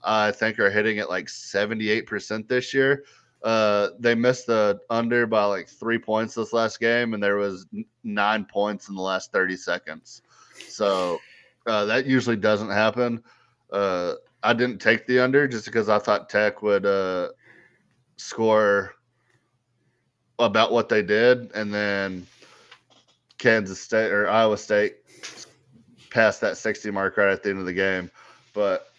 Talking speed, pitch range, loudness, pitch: 155 wpm, 100-120 Hz, -23 LUFS, 110 Hz